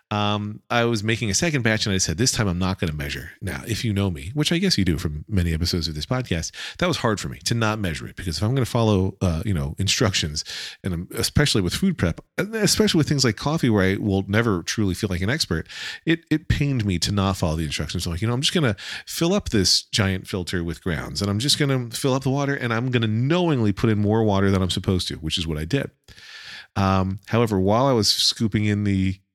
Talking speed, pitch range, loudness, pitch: 265 wpm, 95-120 Hz, -22 LUFS, 105 Hz